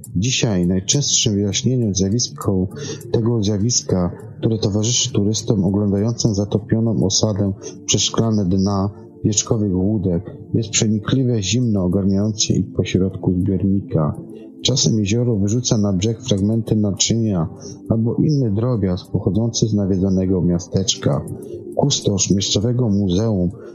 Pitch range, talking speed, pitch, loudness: 95-115 Hz, 100 wpm, 105 Hz, -18 LUFS